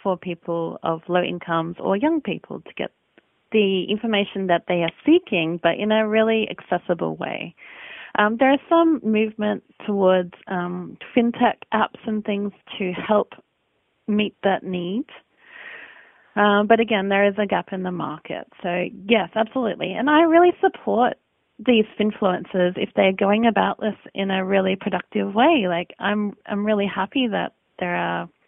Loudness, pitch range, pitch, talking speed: -21 LUFS, 180-220 Hz, 205 Hz, 160 wpm